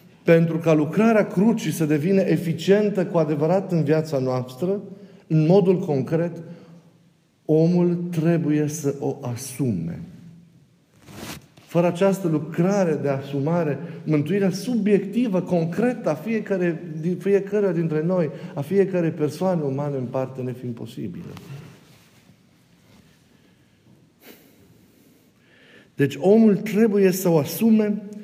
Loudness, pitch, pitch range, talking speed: -22 LUFS, 170 Hz, 155-195 Hz, 105 wpm